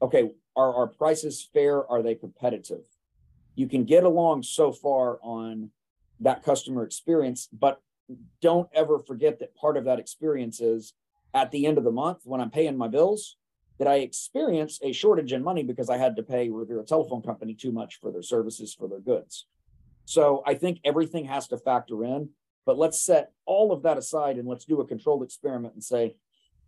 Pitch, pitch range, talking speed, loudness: 135 Hz, 120-155 Hz, 190 wpm, -26 LUFS